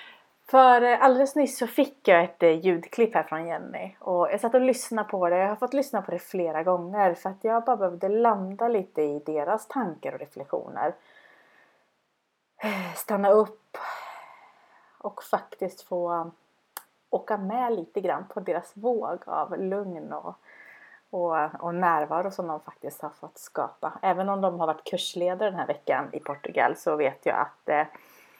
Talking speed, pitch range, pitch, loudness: 160 wpm, 175-230 Hz, 190 Hz, -26 LUFS